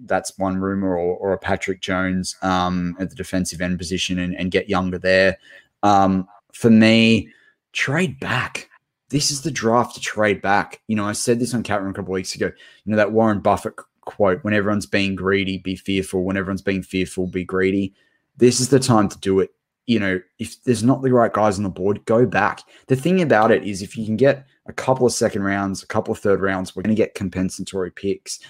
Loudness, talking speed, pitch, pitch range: -20 LUFS, 225 wpm, 100 Hz, 95-110 Hz